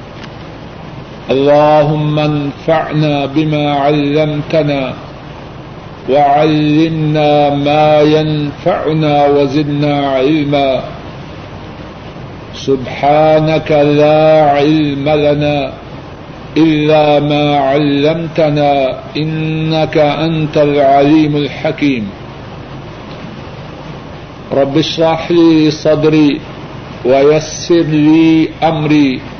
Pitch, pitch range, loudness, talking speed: 150 Hz, 145-155 Hz, -11 LUFS, 55 wpm